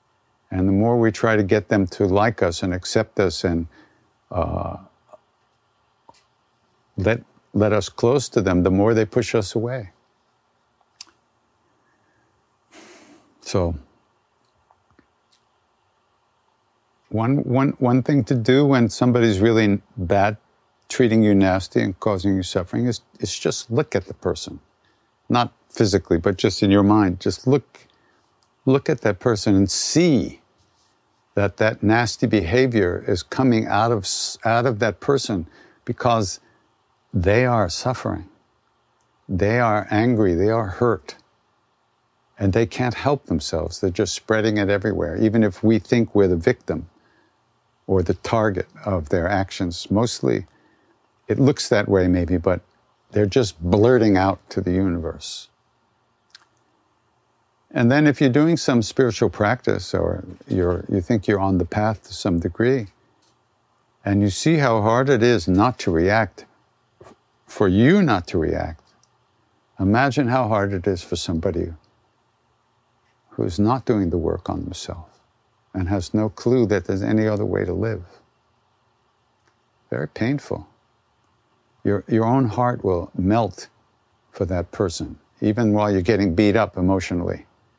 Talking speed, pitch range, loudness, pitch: 140 wpm, 95-120 Hz, -20 LUFS, 105 Hz